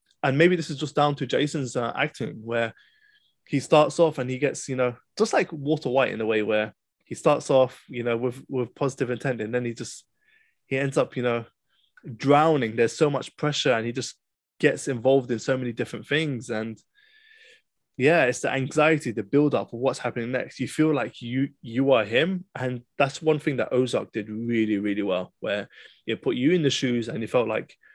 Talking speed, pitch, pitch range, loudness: 215 wpm, 135 Hz, 120-150 Hz, -25 LUFS